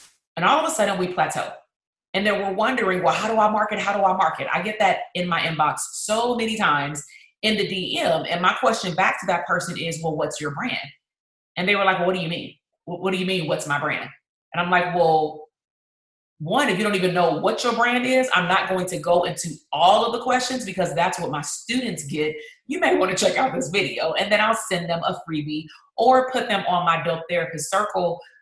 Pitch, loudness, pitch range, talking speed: 180 Hz, -22 LUFS, 165-210 Hz, 240 wpm